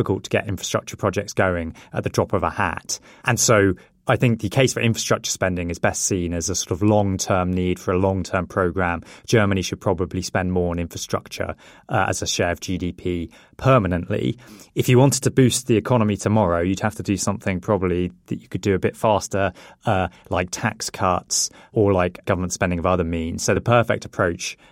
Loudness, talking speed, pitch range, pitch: -21 LUFS, 205 wpm, 90-110 Hz, 100 Hz